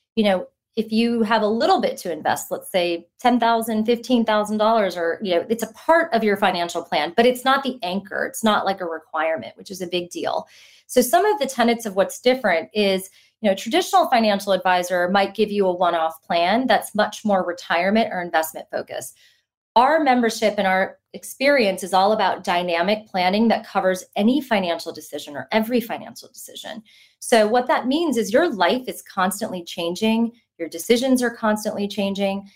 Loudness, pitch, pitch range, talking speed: -21 LUFS, 210 Hz, 185-230 Hz, 190 wpm